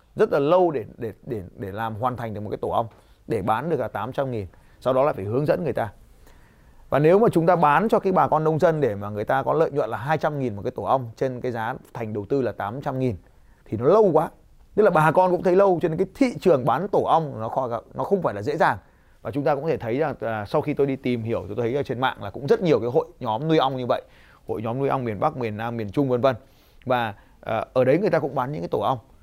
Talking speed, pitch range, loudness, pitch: 295 wpm, 115-155 Hz, -23 LUFS, 130 Hz